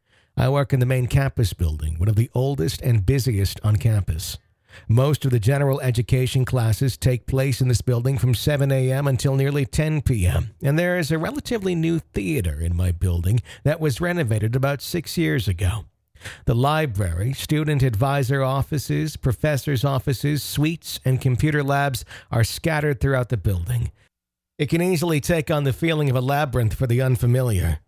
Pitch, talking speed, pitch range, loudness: 130 Hz, 170 wpm, 110-145 Hz, -22 LUFS